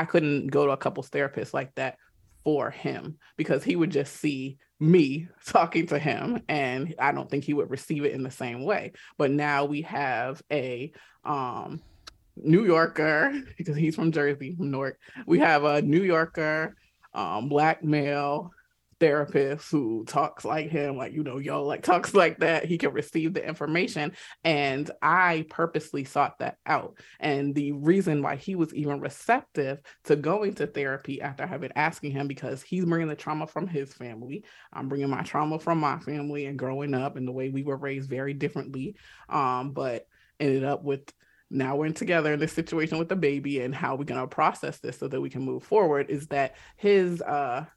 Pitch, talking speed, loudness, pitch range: 145 Hz, 190 wpm, -27 LUFS, 140-160 Hz